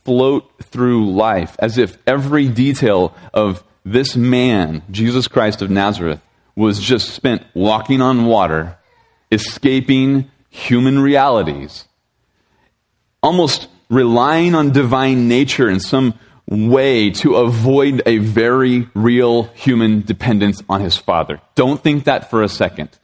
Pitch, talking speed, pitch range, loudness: 120 Hz, 120 wpm, 105-130 Hz, -15 LUFS